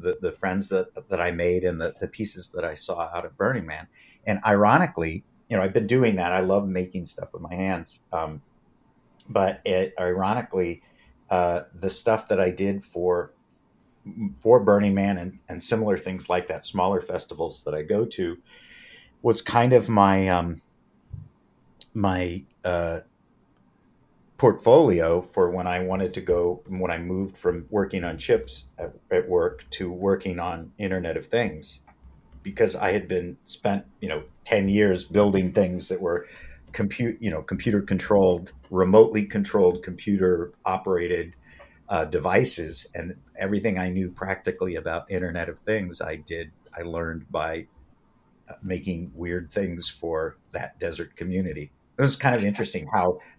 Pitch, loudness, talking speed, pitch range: 90 Hz, -25 LUFS, 155 wpm, 85-100 Hz